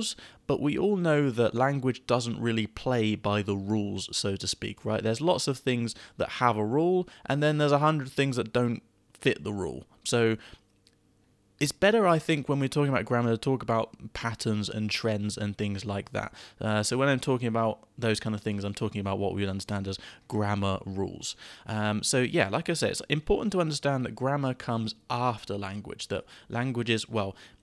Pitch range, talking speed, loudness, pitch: 105-135 Hz, 205 wpm, -29 LUFS, 115 Hz